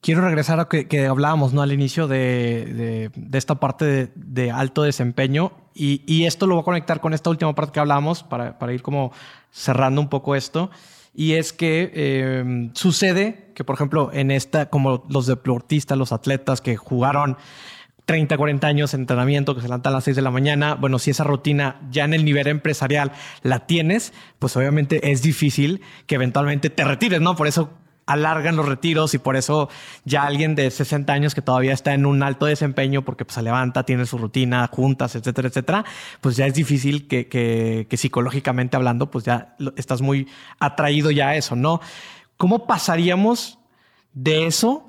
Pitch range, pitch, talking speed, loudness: 130-155 Hz, 145 Hz, 190 wpm, -20 LUFS